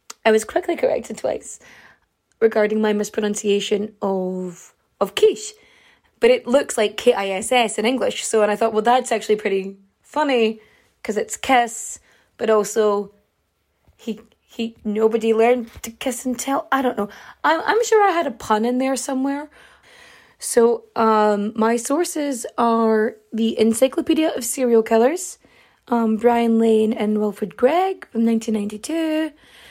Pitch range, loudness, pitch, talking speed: 215-270 Hz, -20 LUFS, 230 Hz, 145 wpm